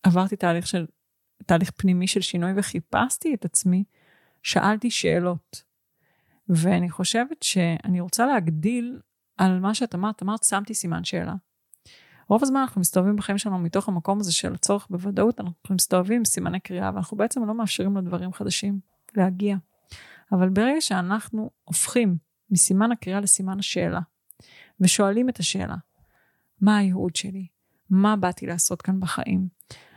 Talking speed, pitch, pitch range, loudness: 135 wpm, 190 Hz, 180-210 Hz, -23 LUFS